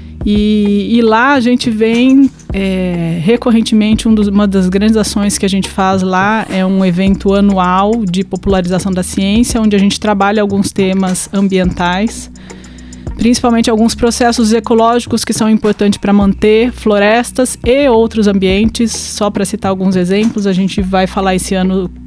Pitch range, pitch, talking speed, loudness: 190-225 Hz, 205 Hz, 160 wpm, -11 LUFS